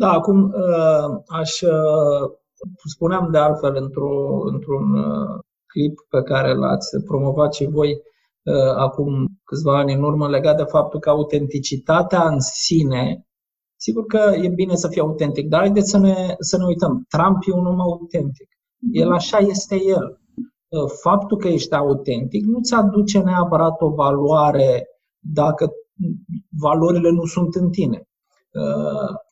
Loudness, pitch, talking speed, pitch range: -18 LUFS, 165 Hz, 135 wpm, 145-190 Hz